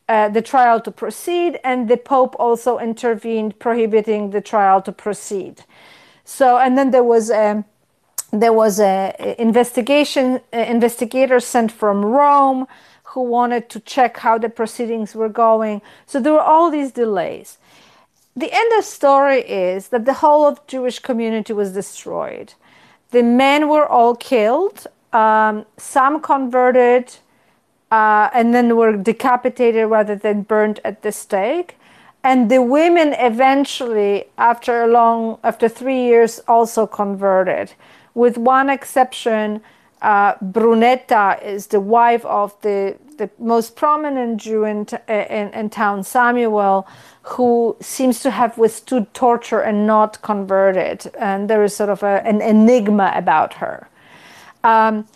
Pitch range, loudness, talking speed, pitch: 215-255 Hz, -16 LUFS, 140 wpm, 230 Hz